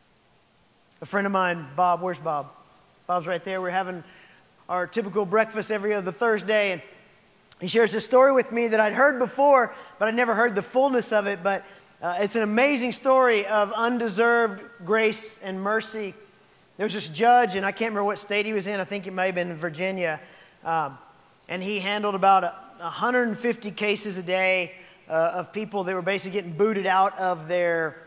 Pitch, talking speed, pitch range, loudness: 205 Hz, 190 wpm, 185-220 Hz, -24 LUFS